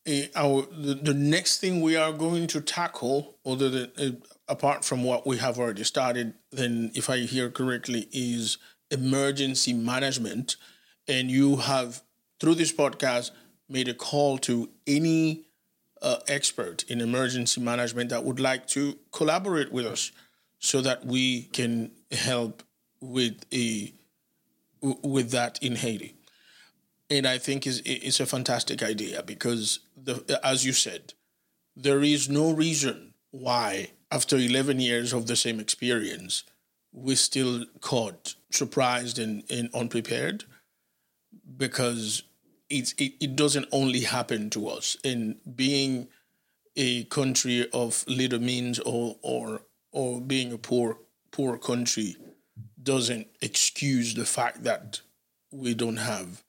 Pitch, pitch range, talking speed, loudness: 130 Hz, 120-140 Hz, 135 wpm, -27 LUFS